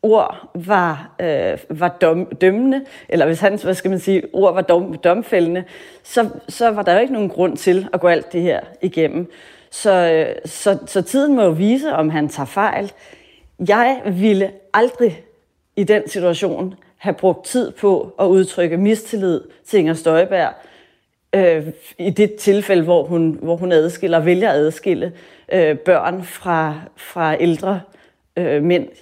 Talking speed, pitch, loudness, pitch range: 155 wpm, 185 Hz, -17 LUFS, 170-200 Hz